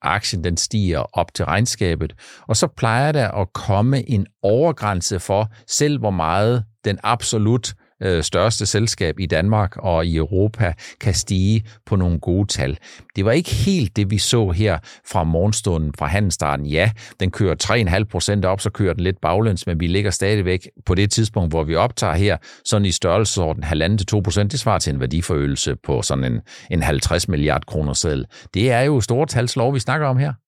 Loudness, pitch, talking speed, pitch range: -19 LUFS, 100 Hz, 190 wpm, 90-110 Hz